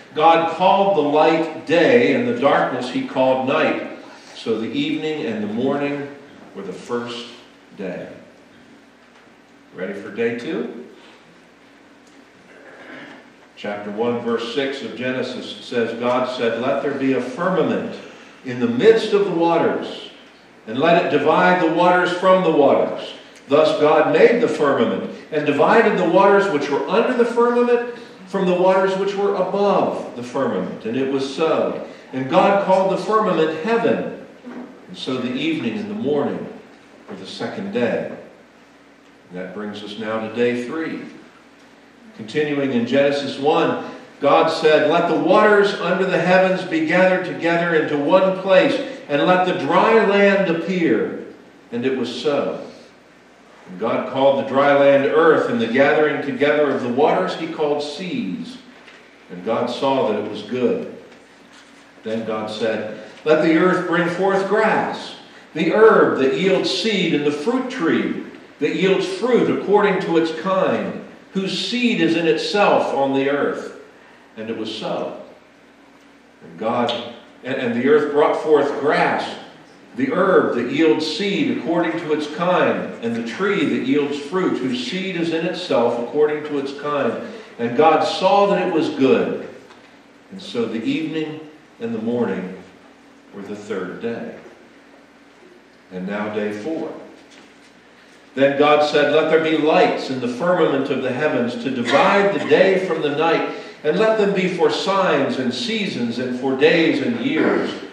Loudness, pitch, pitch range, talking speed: -18 LUFS, 170 Hz, 140-215 Hz, 155 wpm